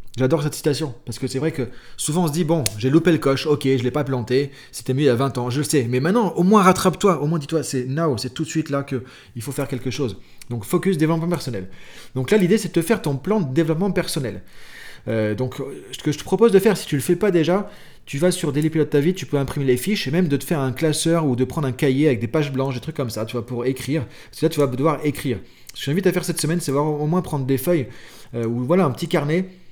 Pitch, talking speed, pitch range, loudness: 150 Hz, 300 wpm, 130-170 Hz, -21 LUFS